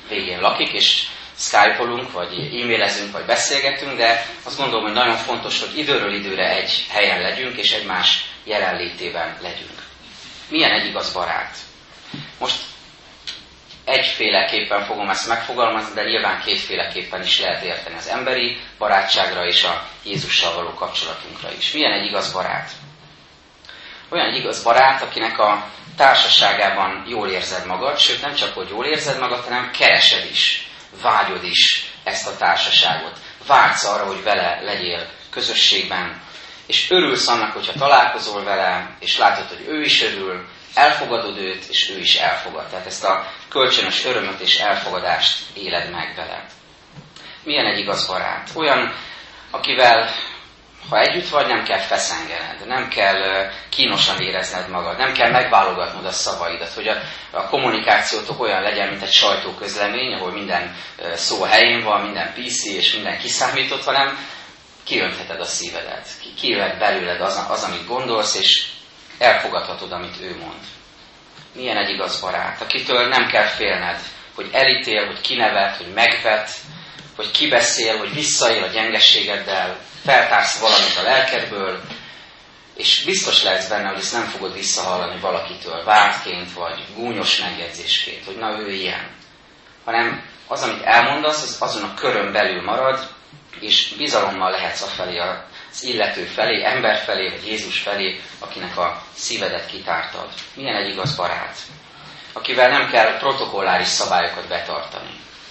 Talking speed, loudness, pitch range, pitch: 140 wpm, -18 LUFS, 95-125 Hz, 105 Hz